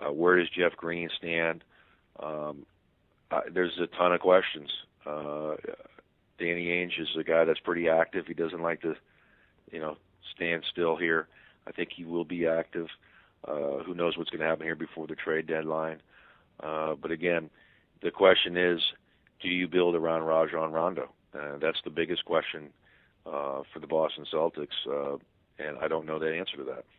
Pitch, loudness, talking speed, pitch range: 80 Hz, -30 LUFS, 180 wpm, 80-85 Hz